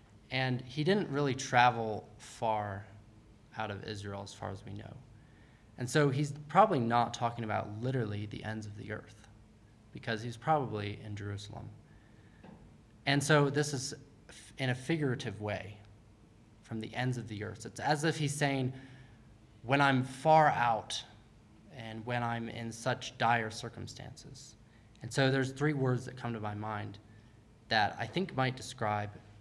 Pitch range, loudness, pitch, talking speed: 110-130 Hz, -33 LUFS, 115 Hz, 155 wpm